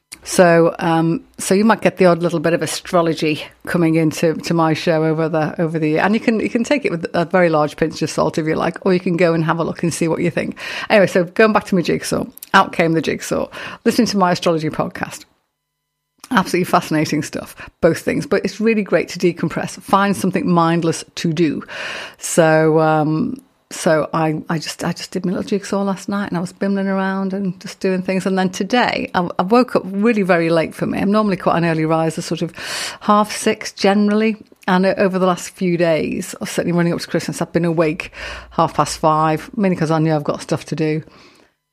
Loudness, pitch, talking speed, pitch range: -17 LUFS, 180 Hz, 225 wpm, 160-200 Hz